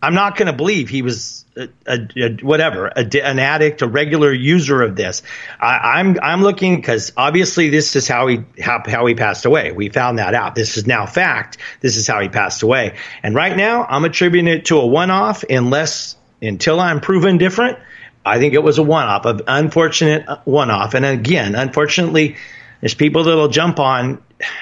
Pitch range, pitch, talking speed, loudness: 125-165 Hz, 150 Hz, 195 wpm, -15 LUFS